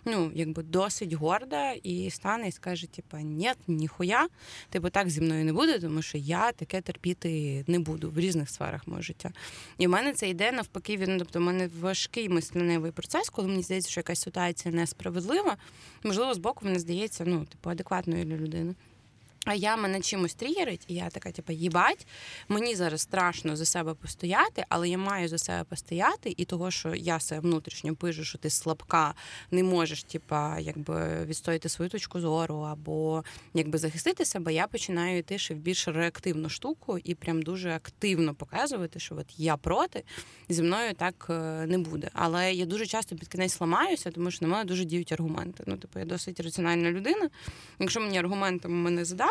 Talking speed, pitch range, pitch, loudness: 185 wpm, 160-185 Hz, 175 Hz, -30 LUFS